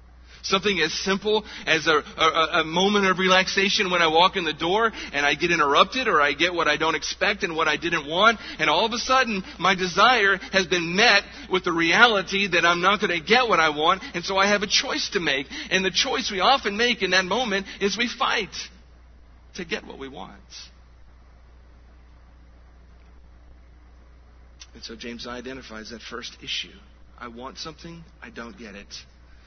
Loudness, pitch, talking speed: -21 LUFS, 165 Hz, 190 wpm